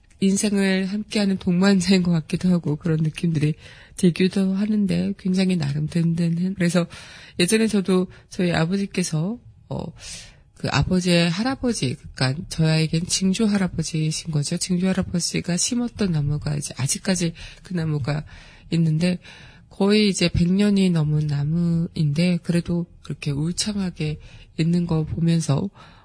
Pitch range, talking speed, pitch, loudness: 155-190 Hz, 310 characters per minute, 175 Hz, -22 LUFS